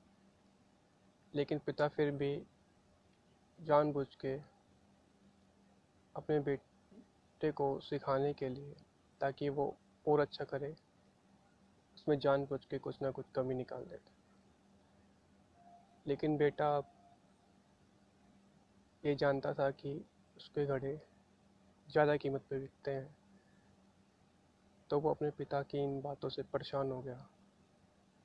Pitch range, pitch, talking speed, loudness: 135-145 Hz, 140 Hz, 110 wpm, -38 LUFS